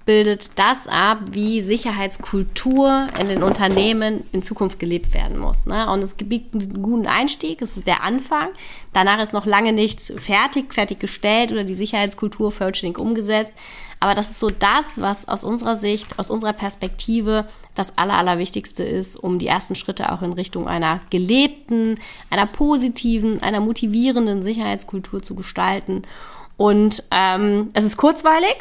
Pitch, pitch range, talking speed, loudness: 210 Hz, 195-230 Hz, 150 wpm, -19 LUFS